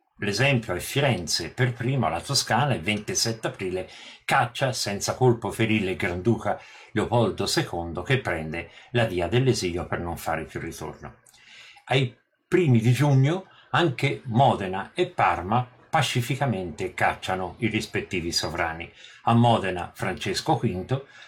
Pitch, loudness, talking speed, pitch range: 115 Hz, -25 LUFS, 125 wpm, 90-130 Hz